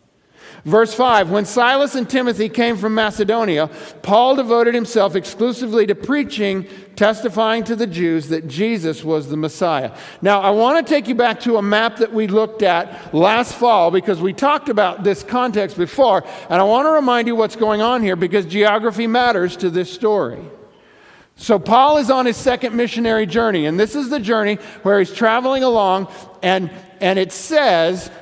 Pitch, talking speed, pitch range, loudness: 215 Hz, 180 wpm, 190-240 Hz, -16 LUFS